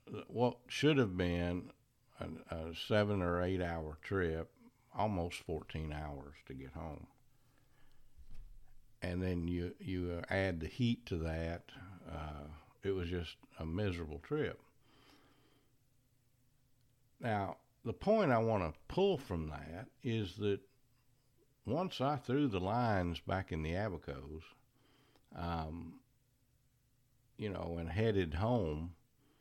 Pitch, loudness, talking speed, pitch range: 100 Hz, -38 LUFS, 120 wpm, 85-125 Hz